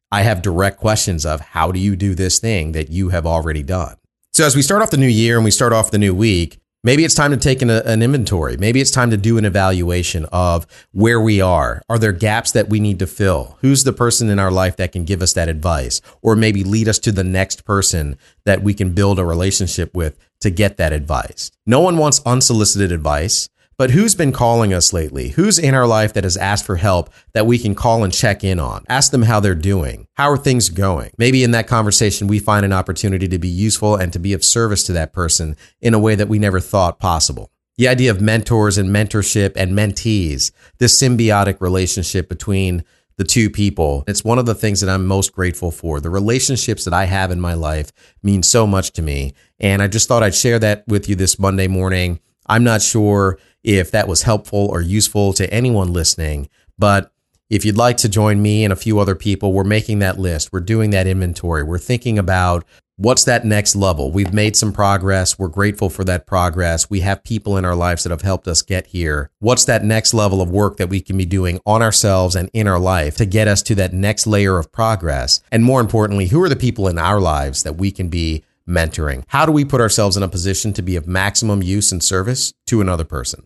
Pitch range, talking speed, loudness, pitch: 90-110 Hz, 230 wpm, -15 LUFS, 100 Hz